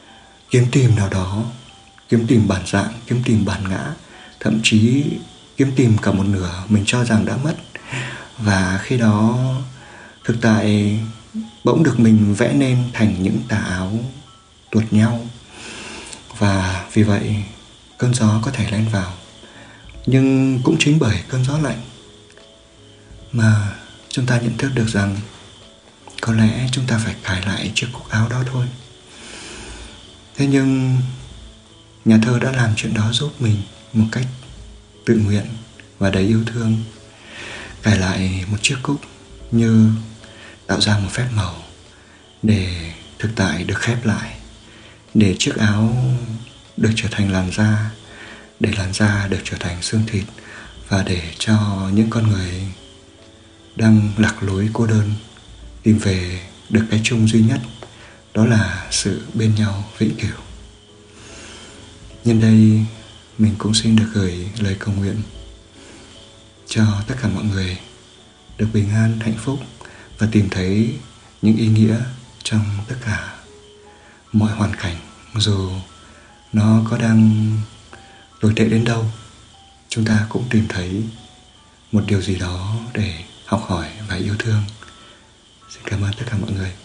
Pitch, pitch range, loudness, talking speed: 110 Hz, 100-115 Hz, -18 LUFS, 145 wpm